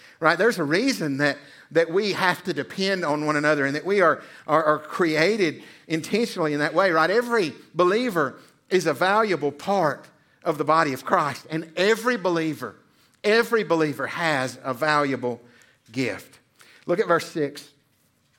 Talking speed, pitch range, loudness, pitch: 160 wpm, 145-185 Hz, -23 LUFS, 155 Hz